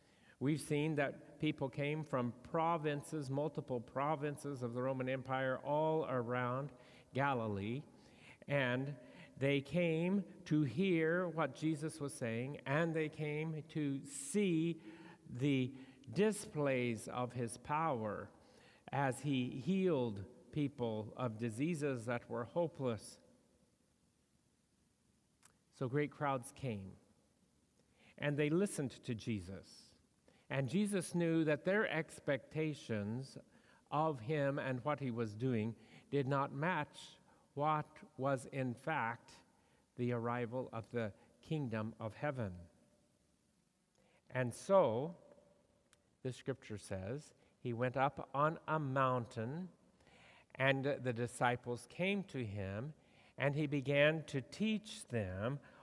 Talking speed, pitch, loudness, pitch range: 110 wpm, 140 Hz, -39 LUFS, 125-155 Hz